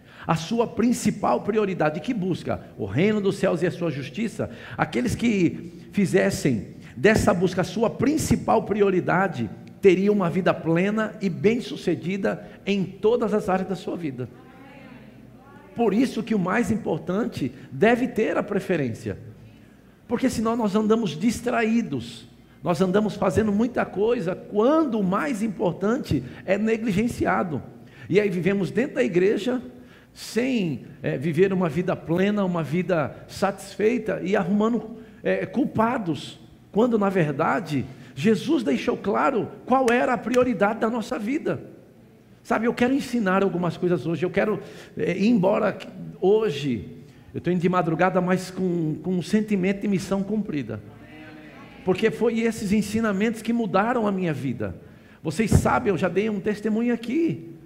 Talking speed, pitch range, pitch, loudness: 145 wpm, 170-225 Hz, 195 Hz, -24 LUFS